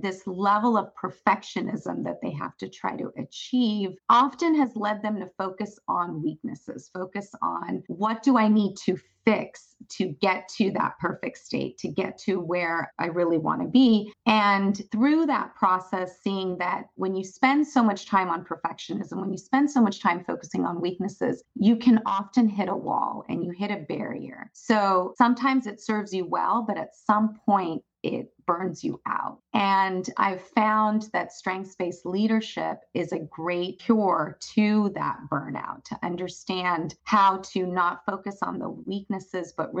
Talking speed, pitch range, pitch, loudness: 175 wpm, 185-215 Hz, 200 Hz, -26 LUFS